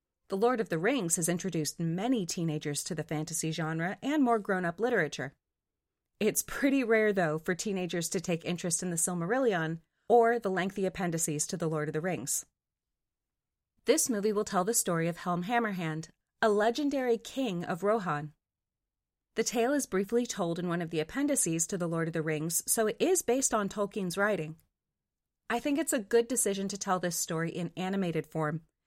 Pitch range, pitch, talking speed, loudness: 165-225 Hz, 185 Hz, 185 wpm, -30 LUFS